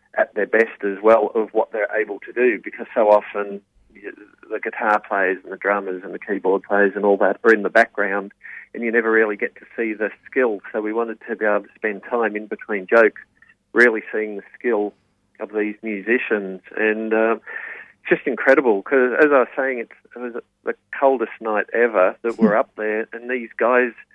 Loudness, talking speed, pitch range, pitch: -20 LUFS, 205 wpm, 100-115 Hz, 110 Hz